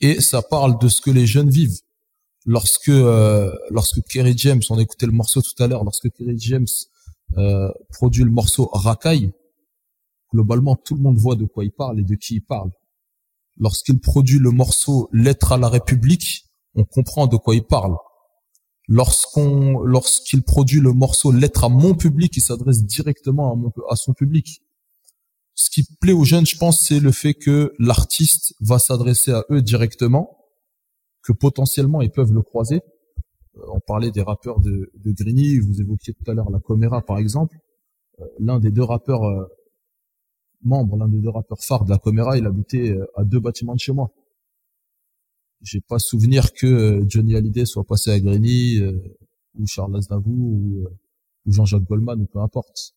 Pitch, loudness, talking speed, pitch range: 120 Hz, -17 LUFS, 180 wpm, 105-140 Hz